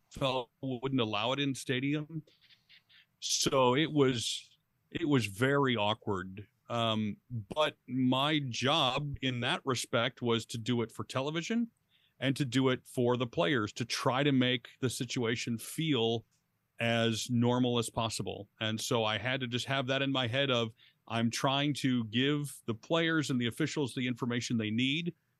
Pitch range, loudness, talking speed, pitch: 115-140 Hz, -32 LUFS, 165 wpm, 130 Hz